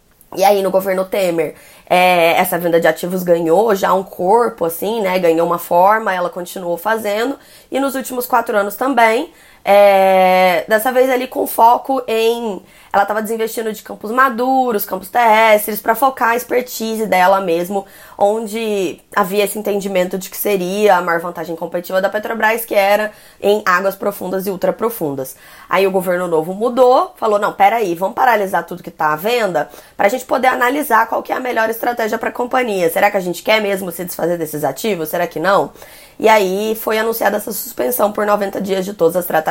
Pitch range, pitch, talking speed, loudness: 180-225 Hz, 200 Hz, 190 wpm, -15 LUFS